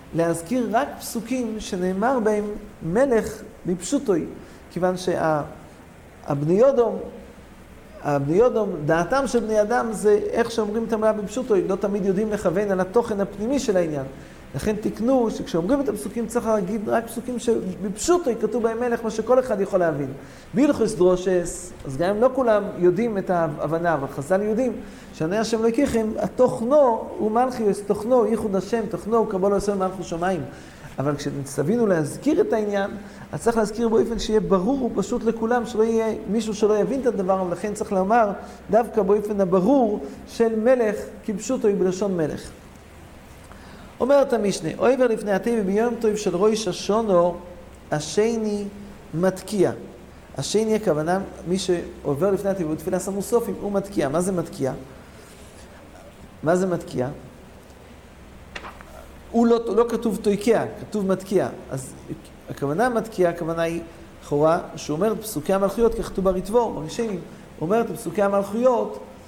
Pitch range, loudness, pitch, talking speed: 175-230 Hz, -23 LUFS, 205 Hz, 140 wpm